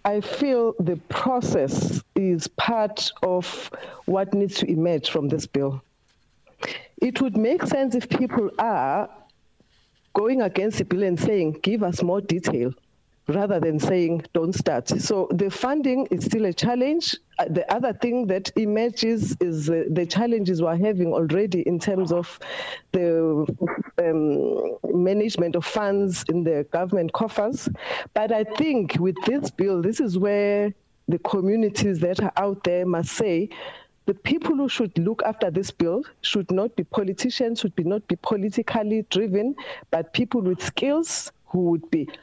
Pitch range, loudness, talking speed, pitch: 175-225 Hz, -24 LUFS, 155 wpm, 195 Hz